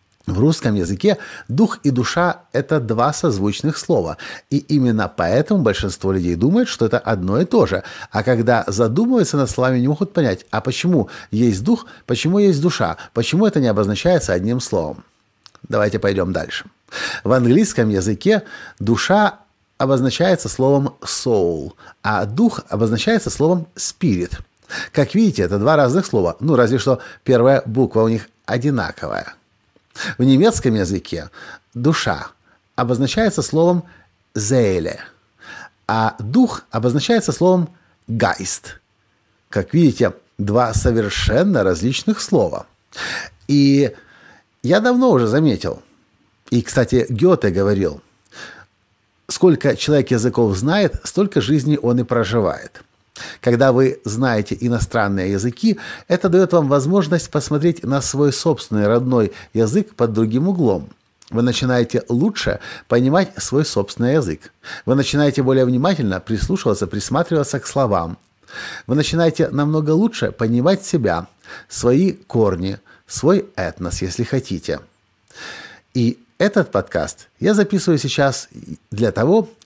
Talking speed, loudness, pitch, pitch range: 120 wpm, -18 LUFS, 130 Hz, 110-160 Hz